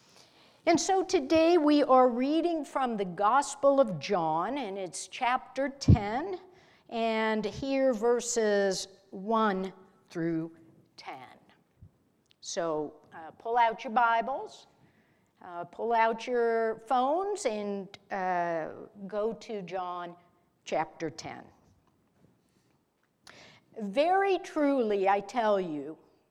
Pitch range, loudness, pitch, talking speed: 190-270 Hz, -29 LUFS, 225 Hz, 100 wpm